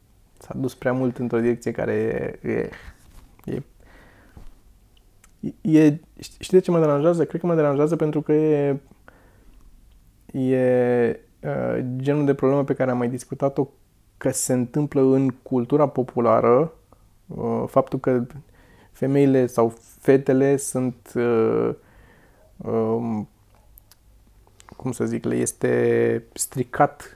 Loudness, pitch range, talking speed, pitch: -22 LUFS, 110-140 Hz, 120 wpm, 125 Hz